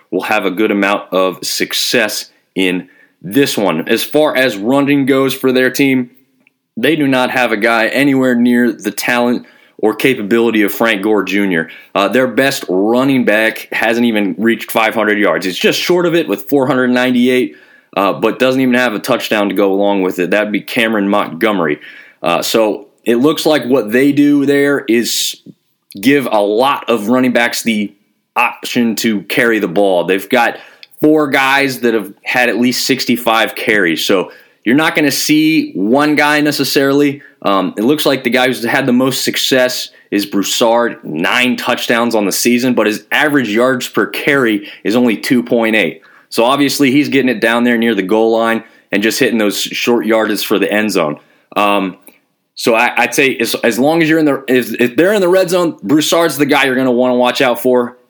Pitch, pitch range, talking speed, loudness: 125 Hz, 110-135 Hz, 195 wpm, -13 LUFS